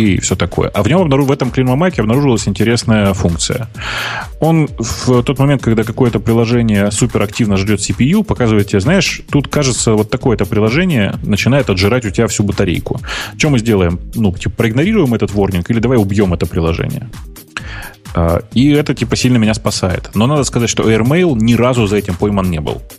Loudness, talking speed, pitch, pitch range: -13 LUFS, 175 wpm, 115 Hz, 100-130 Hz